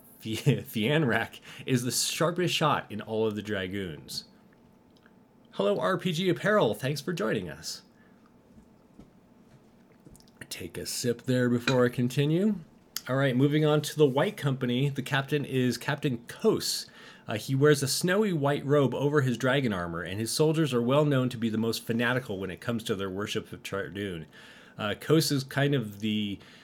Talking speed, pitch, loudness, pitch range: 165 wpm, 130 Hz, -28 LUFS, 115-150 Hz